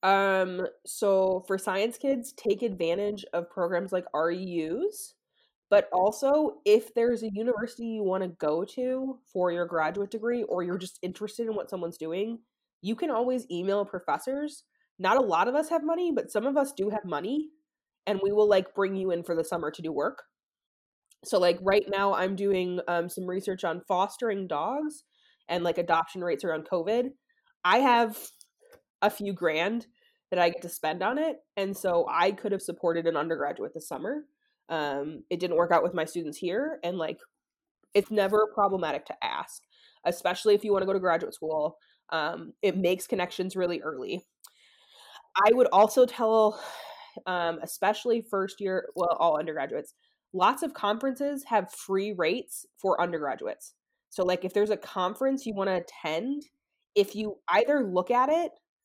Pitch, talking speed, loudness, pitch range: 200 Hz, 175 wpm, -28 LUFS, 180-250 Hz